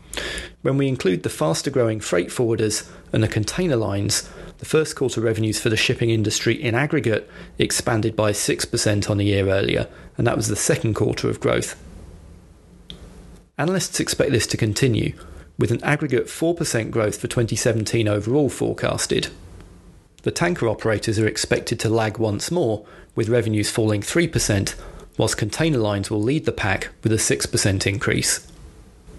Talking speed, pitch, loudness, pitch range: 155 wpm, 110 Hz, -21 LUFS, 105-120 Hz